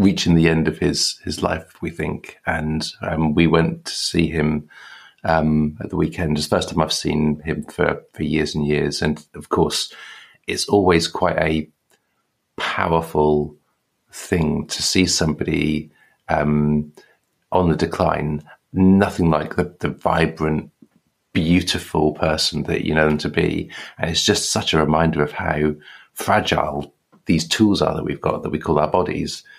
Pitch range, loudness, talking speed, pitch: 75-85 Hz, -20 LUFS, 165 wpm, 80 Hz